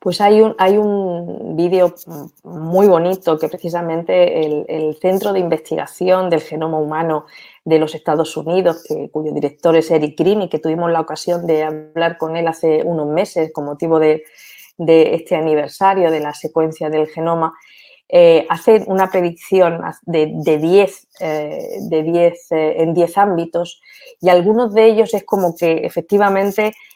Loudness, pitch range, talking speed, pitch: -16 LUFS, 160-185 Hz, 165 wpm, 170 Hz